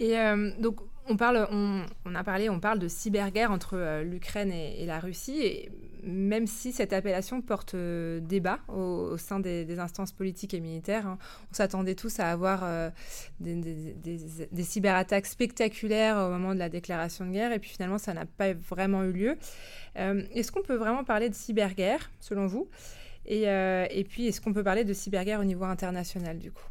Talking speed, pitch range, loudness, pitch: 205 wpm, 180-215 Hz, -31 LUFS, 195 Hz